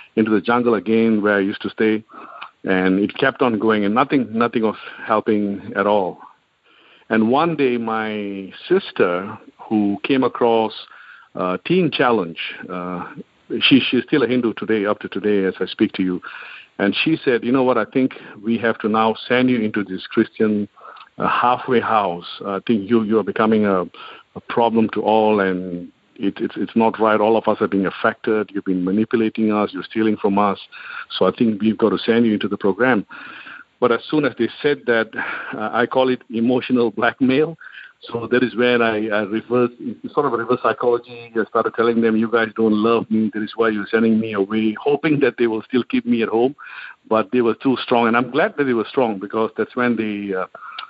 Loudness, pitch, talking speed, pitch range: -19 LUFS, 110 Hz, 205 wpm, 105-120 Hz